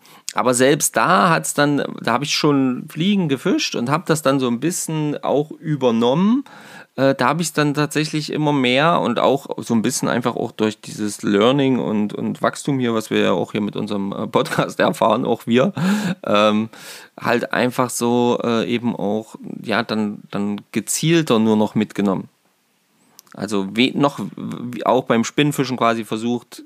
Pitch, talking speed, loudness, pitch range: 130 Hz, 165 wpm, -19 LUFS, 110-155 Hz